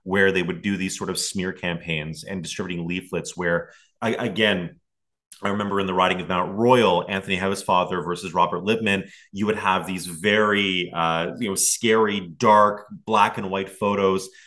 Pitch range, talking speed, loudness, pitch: 90-100 Hz, 180 wpm, -22 LUFS, 95 Hz